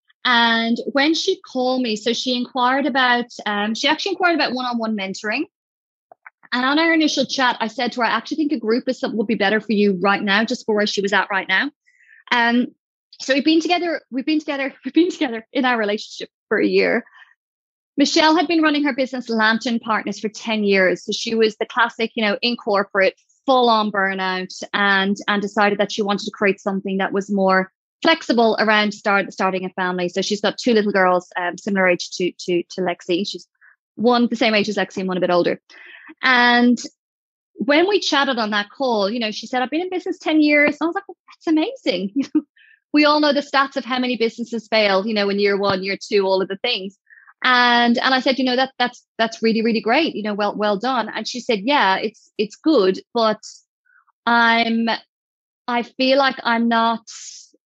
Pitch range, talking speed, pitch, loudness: 205-270 Hz, 210 wpm, 230 Hz, -19 LUFS